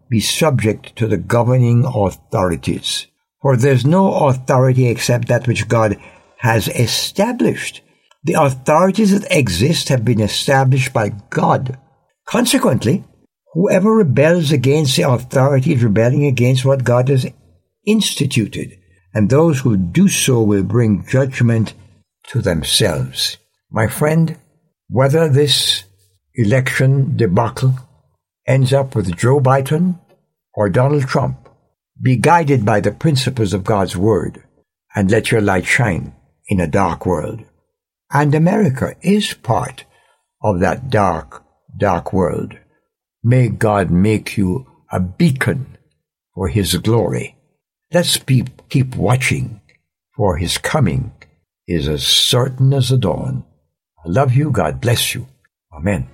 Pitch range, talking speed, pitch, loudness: 110-145 Hz, 125 wpm, 130 Hz, -15 LUFS